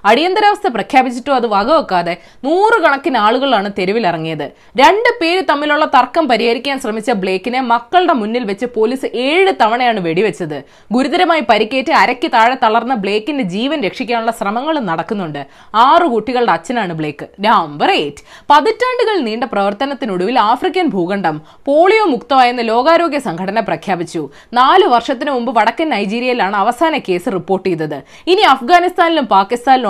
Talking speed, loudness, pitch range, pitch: 115 wpm, -13 LUFS, 200-310 Hz, 245 Hz